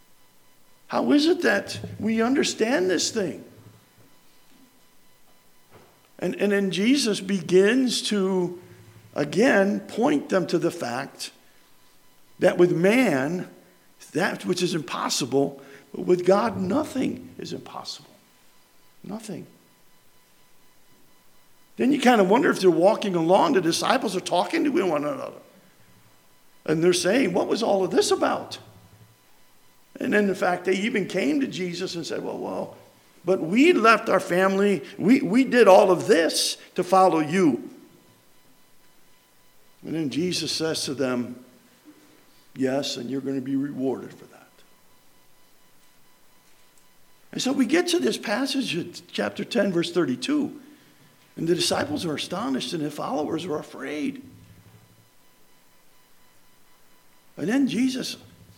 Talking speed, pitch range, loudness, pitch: 130 wpm, 170-260 Hz, -23 LUFS, 195 Hz